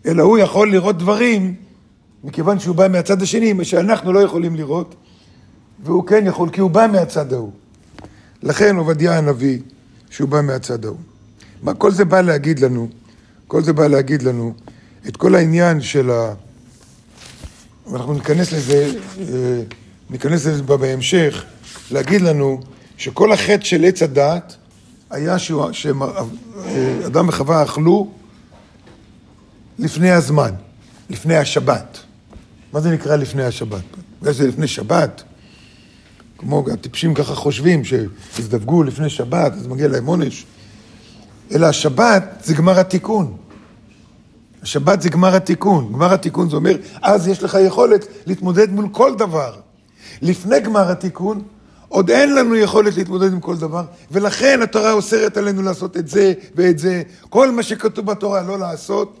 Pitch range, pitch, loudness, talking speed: 130-190 Hz, 165 Hz, -16 LUFS, 135 wpm